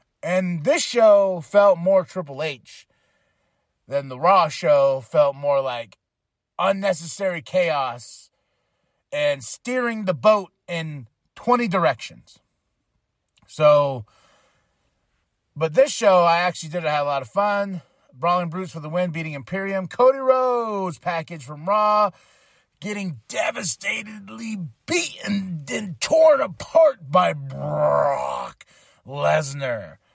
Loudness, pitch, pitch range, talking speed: -21 LUFS, 185 Hz, 150-210 Hz, 110 wpm